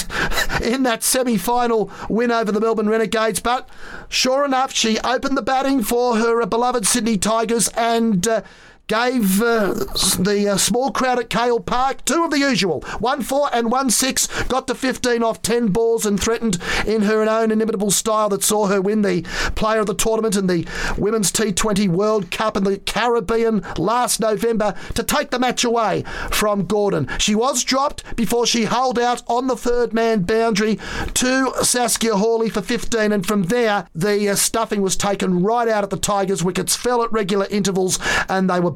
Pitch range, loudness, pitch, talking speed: 205-240 Hz, -18 LUFS, 225 Hz, 185 wpm